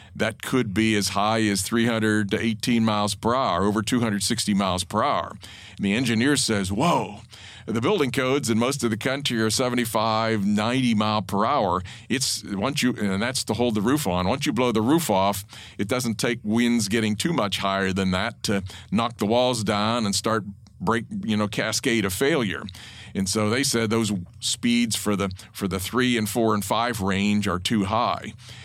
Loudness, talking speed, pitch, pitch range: -23 LUFS, 195 wpm, 110 Hz, 100-120 Hz